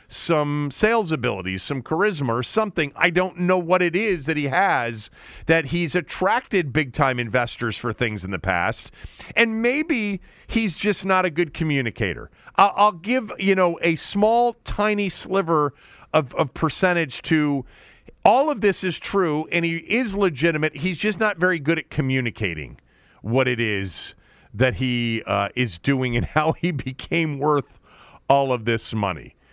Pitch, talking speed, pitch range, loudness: 160 Hz, 165 wpm, 125-190 Hz, -22 LUFS